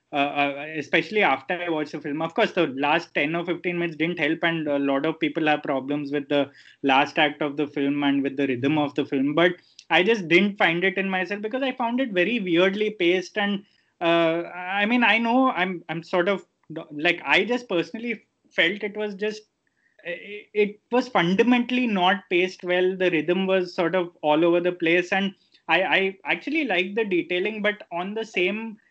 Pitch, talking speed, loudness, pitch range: 180 Hz, 205 wpm, -23 LUFS, 160-205 Hz